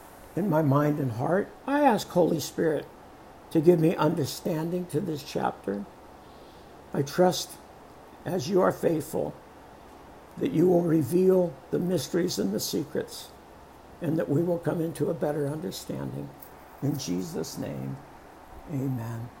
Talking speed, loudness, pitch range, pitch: 135 wpm, -27 LUFS, 130-175 Hz, 150 Hz